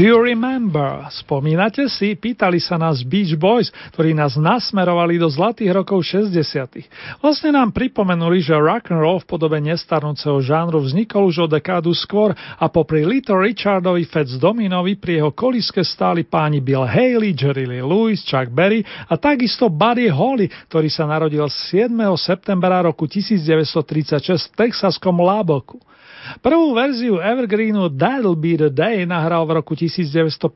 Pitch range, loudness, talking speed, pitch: 155-210 Hz, -17 LUFS, 145 wpm, 175 Hz